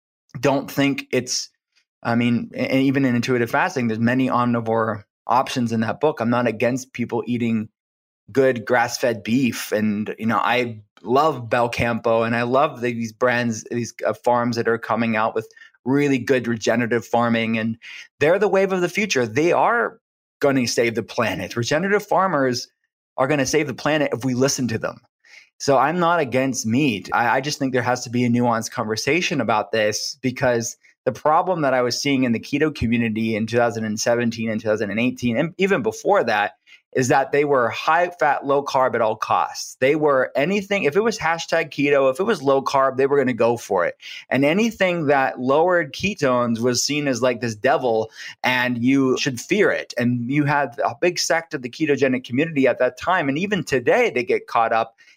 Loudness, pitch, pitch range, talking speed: -20 LUFS, 125 Hz, 115-140 Hz, 195 wpm